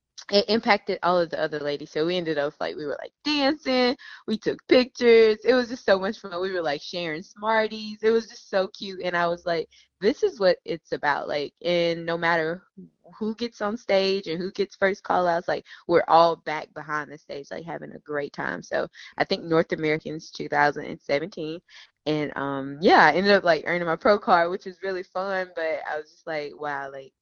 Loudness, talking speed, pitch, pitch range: -24 LUFS, 225 wpm, 180 Hz, 155-210 Hz